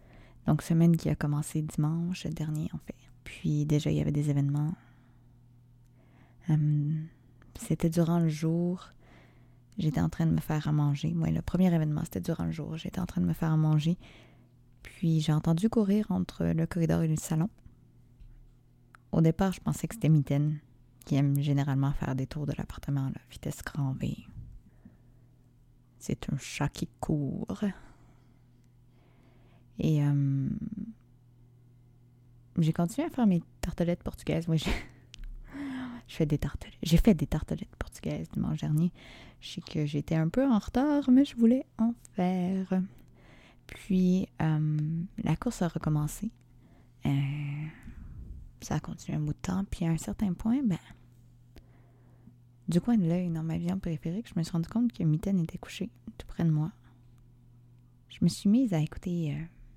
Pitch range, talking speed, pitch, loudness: 125-170 Hz, 160 wpm, 150 Hz, -30 LUFS